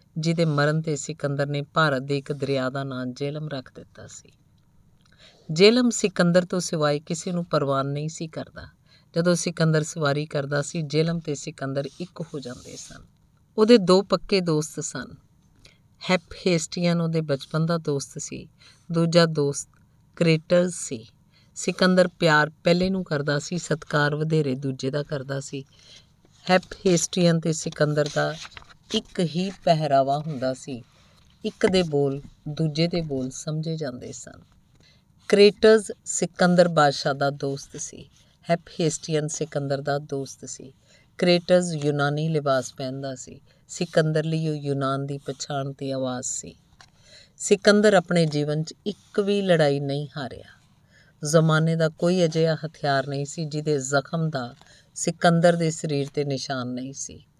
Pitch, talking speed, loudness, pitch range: 150 Hz, 140 wpm, -24 LUFS, 140-170 Hz